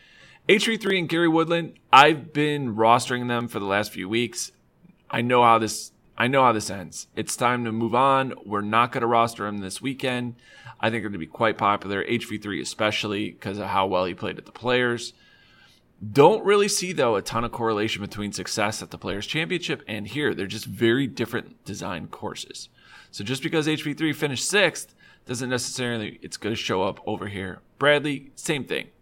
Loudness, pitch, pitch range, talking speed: -24 LUFS, 120 Hz, 105-135 Hz, 195 wpm